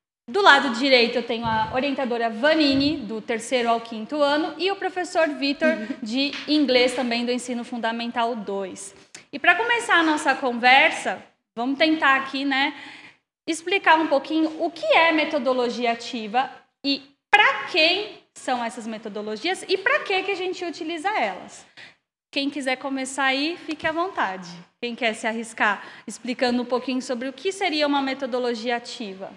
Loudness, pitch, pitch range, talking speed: -22 LUFS, 270 Hz, 240-315 Hz, 155 wpm